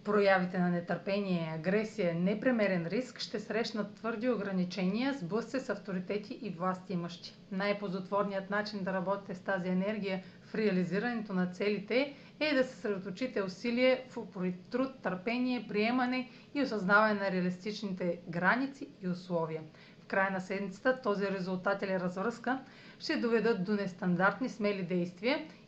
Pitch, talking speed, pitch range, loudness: 200 Hz, 140 wpm, 185-230 Hz, -33 LUFS